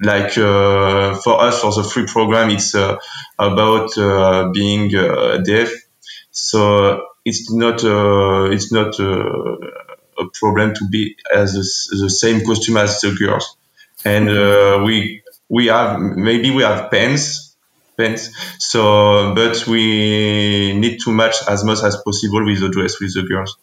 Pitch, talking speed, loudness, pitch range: 105 Hz, 150 wpm, -15 LUFS, 100-115 Hz